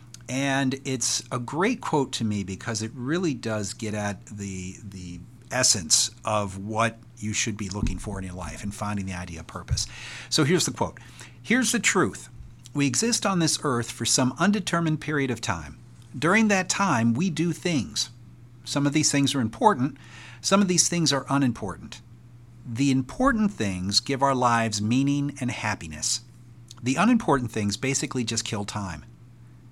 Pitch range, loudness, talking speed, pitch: 110-140 Hz, -25 LUFS, 170 wpm, 120 Hz